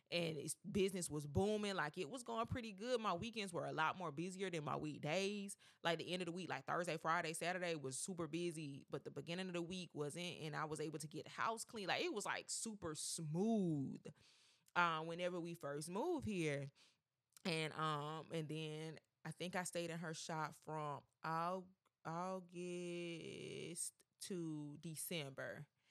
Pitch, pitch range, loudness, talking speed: 170 Hz, 155-180 Hz, -45 LUFS, 175 wpm